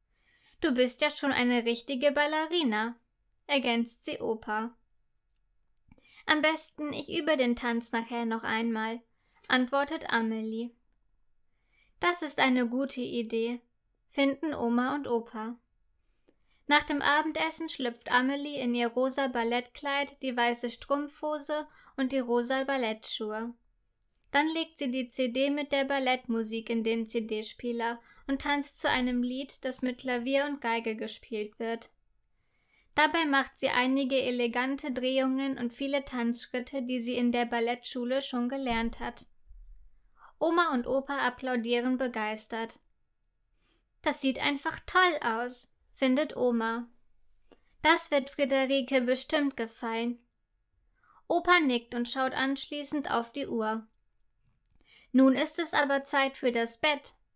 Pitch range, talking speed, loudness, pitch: 235-280 Hz, 125 wpm, -30 LUFS, 255 Hz